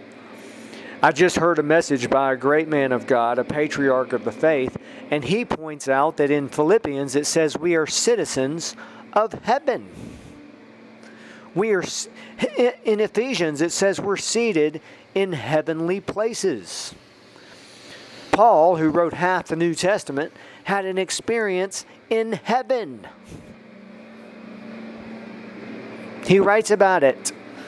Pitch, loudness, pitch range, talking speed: 170 Hz, -21 LUFS, 150-210 Hz, 120 wpm